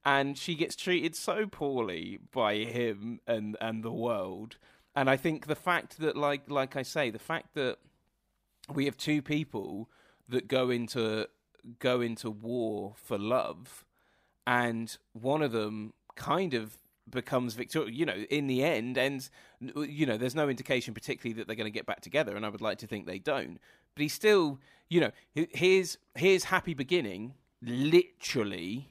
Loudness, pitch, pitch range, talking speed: -32 LUFS, 135 Hz, 115-150 Hz, 170 wpm